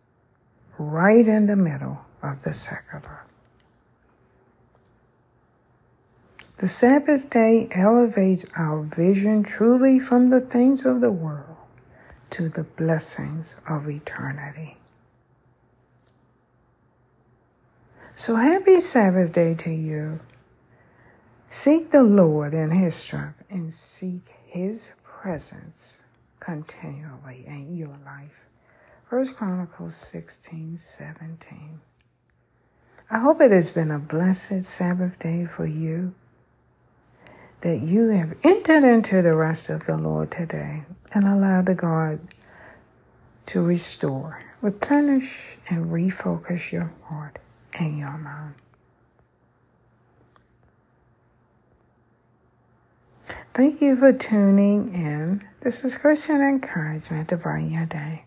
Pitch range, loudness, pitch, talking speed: 130-200 Hz, -21 LUFS, 165 Hz, 100 wpm